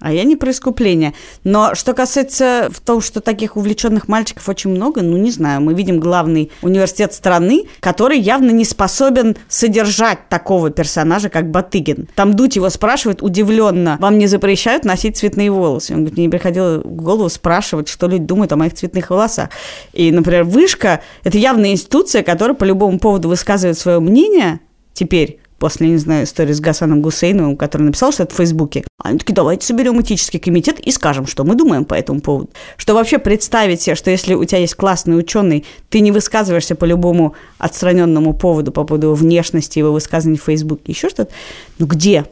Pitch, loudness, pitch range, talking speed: 185 Hz, -14 LUFS, 165-215 Hz, 180 wpm